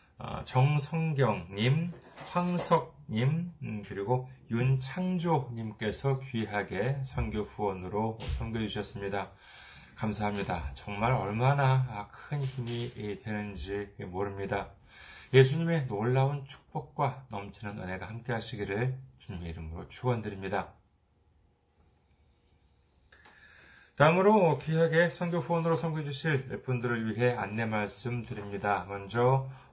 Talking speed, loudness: 250 characters per minute, -31 LUFS